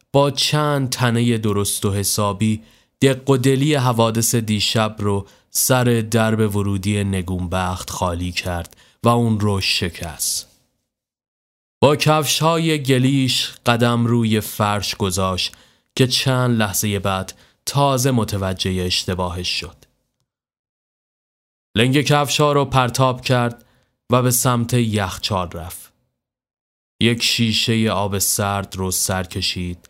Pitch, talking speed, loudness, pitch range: 110 Hz, 110 wpm, -18 LUFS, 95-125 Hz